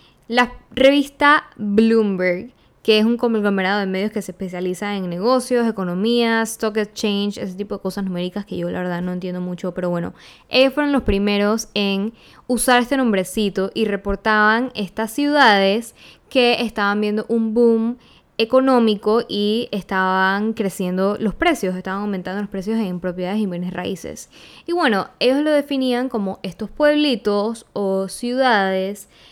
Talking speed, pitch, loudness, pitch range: 150 wpm, 210 Hz, -19 LUFS, 195-235 Hz